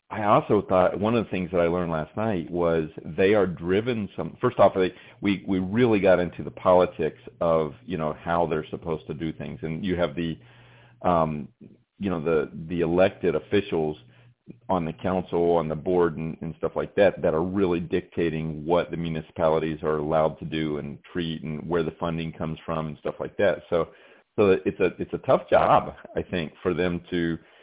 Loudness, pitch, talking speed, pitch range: -25 LUFS, 85 Hz, 200 wpm, 80-90 Hz